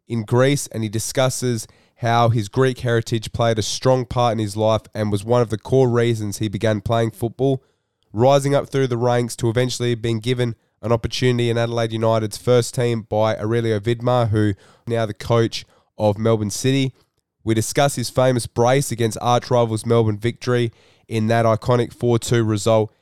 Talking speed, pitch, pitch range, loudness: 175 wpm, 115 Hz, 110-125 Hz, -20 LUFS